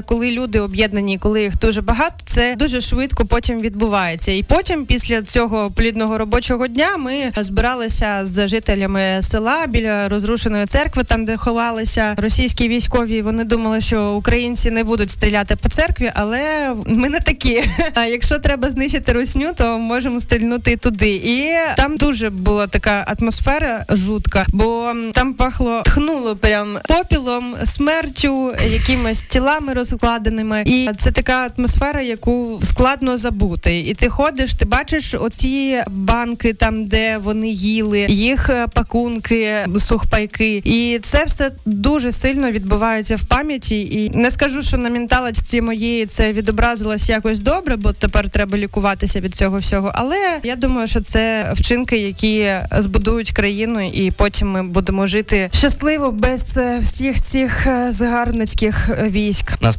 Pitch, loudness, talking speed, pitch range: 230 Hz, -17 LUFS, 140 wpm, 215-255 Hz